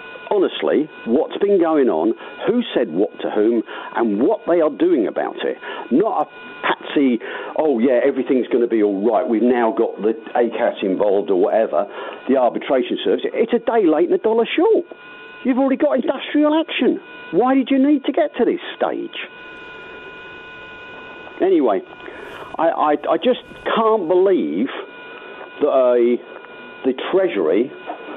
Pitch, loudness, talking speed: 355 Hz, -18 LUFS, 155 wpm